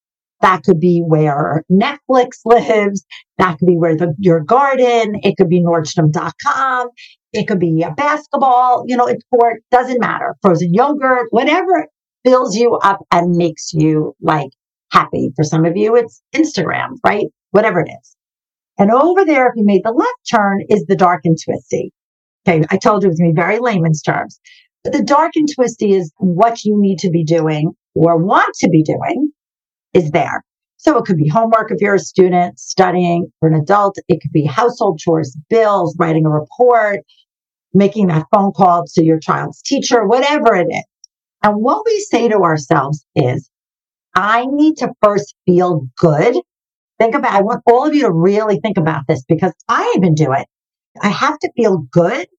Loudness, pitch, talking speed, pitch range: -14 LUFS, 195 Hz, 185 wpm, 170-240 Hz